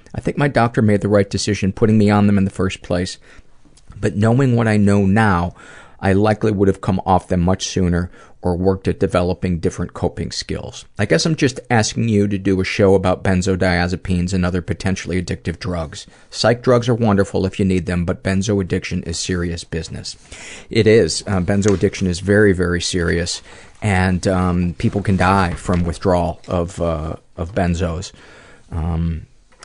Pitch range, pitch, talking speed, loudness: 90-100 Hz, 95 Hz, 180 wpm, -18 LUFS